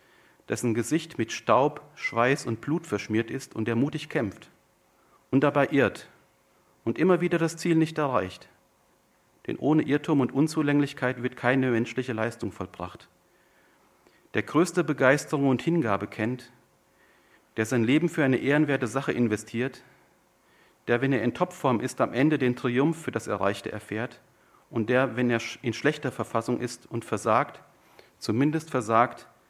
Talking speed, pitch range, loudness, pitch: 150 wpm, 115-145 Hz, -27 LUFS, 125 Hz